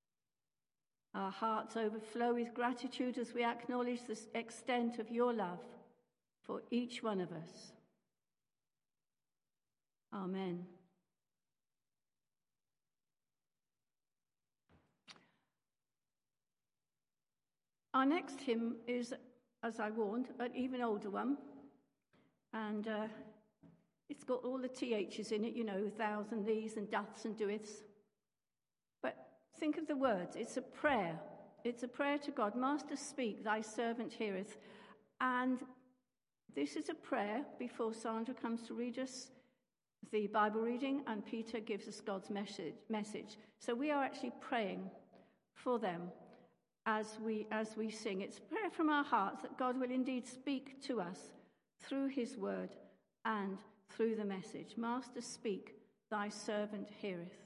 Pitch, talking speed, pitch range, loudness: 225 Hz, 125 wpm, 210-250 Hz, -41 LUFS